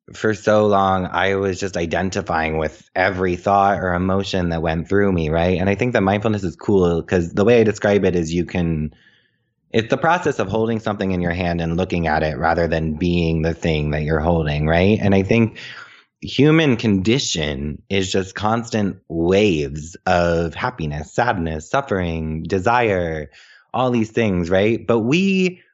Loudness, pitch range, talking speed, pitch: -19 LUFS, 85-105 Hz, 175 wpm, 95 Hz